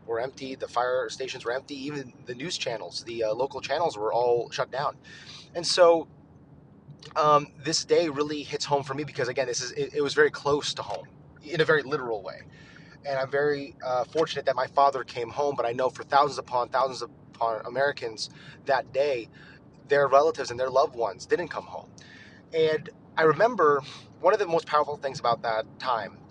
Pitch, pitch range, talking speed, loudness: 140 Hz, 130-150 Hz, 195 wpm, -27 LUFS